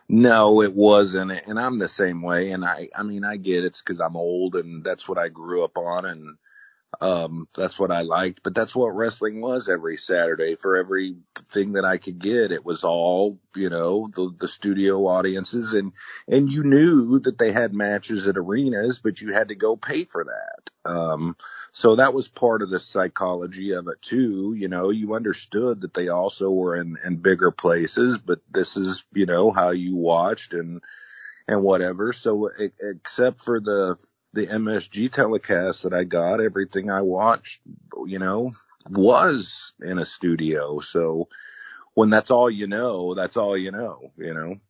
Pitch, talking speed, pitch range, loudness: 95 Hz, 185 wpm, 90-110 Hz, -22 LUFS